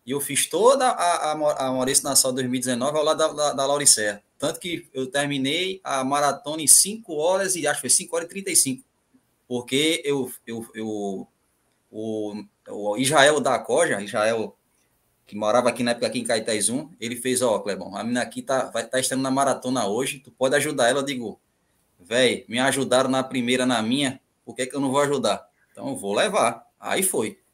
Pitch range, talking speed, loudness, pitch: 125-150 Hz, 205 wpm, -22 LUFS, 130 Hz